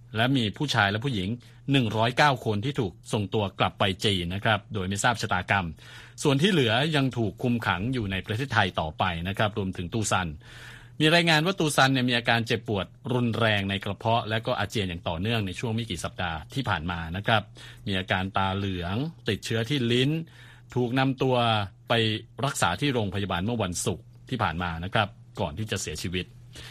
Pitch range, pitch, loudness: 100-125 Hz, 115 Hz, -26 LUFS